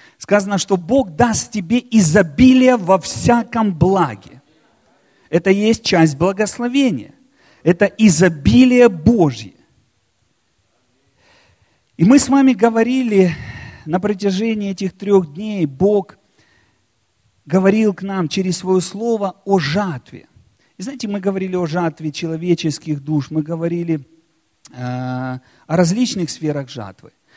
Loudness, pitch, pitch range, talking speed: -16 LUFS, 190 Hz, 160-215 Hz, 110 wpm